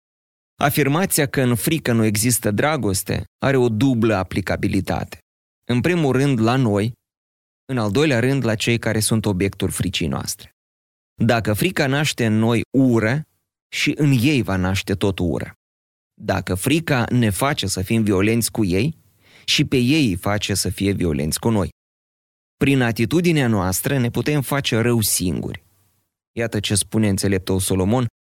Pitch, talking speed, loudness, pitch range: 110 Hz, 155 wpm, -19 LUFS, 95-130 Hz